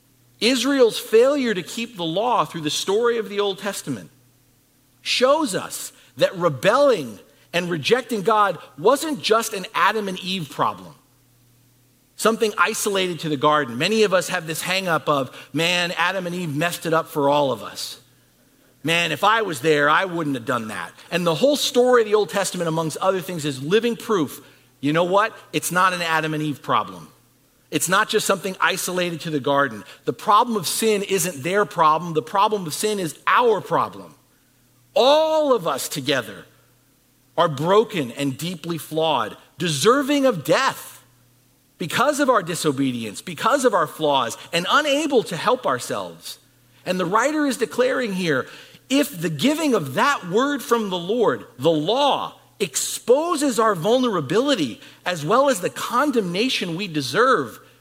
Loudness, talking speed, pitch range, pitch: -21 LUFS, 165 wpm, 150-225 Hz, 180 Hz